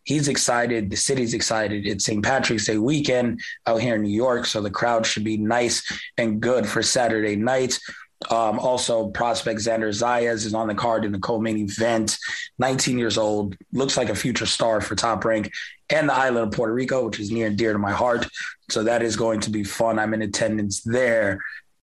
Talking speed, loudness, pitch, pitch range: 205 wpm, -22 LUFS, 115 Hz, 110-120 Hz